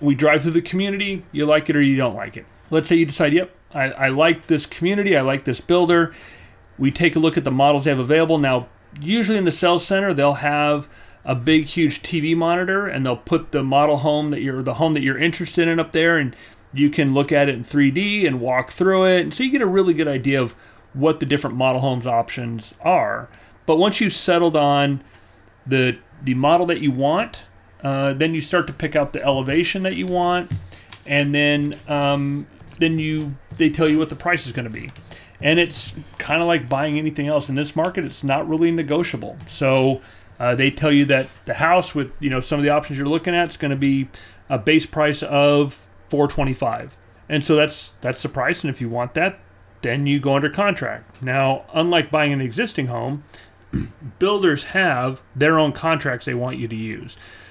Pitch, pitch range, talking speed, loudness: 145 Hz, 130-160 Hz, 215 wpm, -19 LUFS